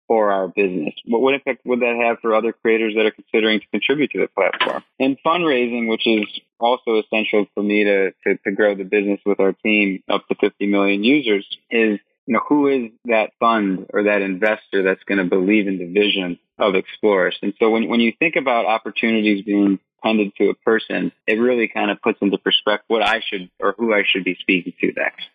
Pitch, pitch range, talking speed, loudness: 105 Hz, 100-115 Hz, 220 wpm, -19 LUFS